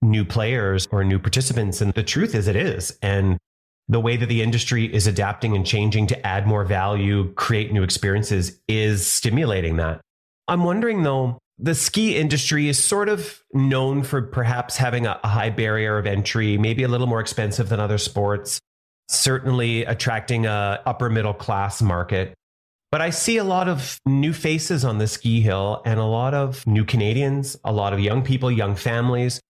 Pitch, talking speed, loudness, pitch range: 115 Hz, 180 wpm, -21 LUFS, 105-130 Hz